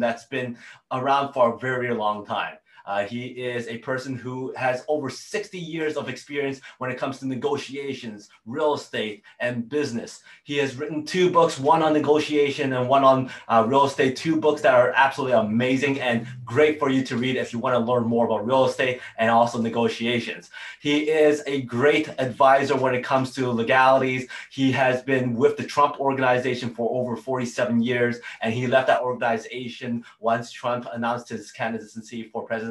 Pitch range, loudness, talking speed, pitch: 120-140 Hz, -23 LUFS, 185 wpm, 130 Hz